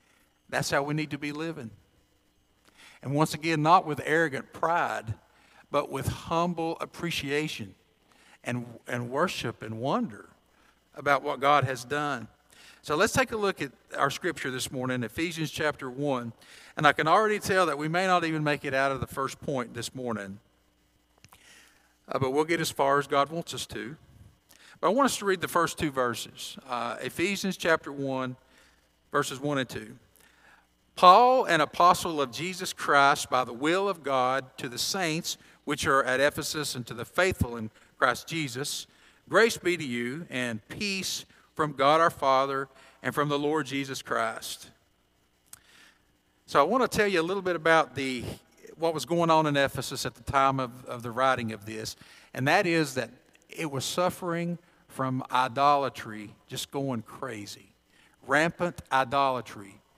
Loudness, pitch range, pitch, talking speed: -27 LUFS, 125-165 Hz, 140 Hz, 170 wpm